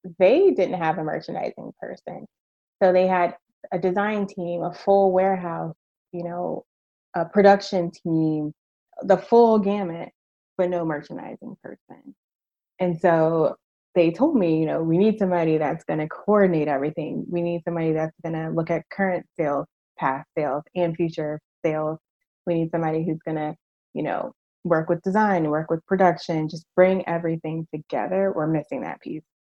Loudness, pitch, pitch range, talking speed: -23 LUFS, 175 Hz, 160-190 Hz, 160 wpm